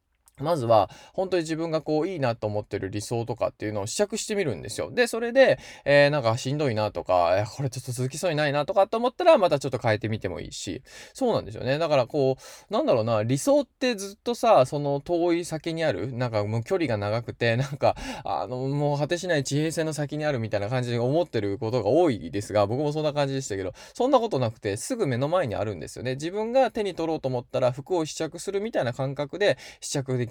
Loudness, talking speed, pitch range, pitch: -26 LUFS, 475 characters per minute, 120-175 Hz, 140 Hz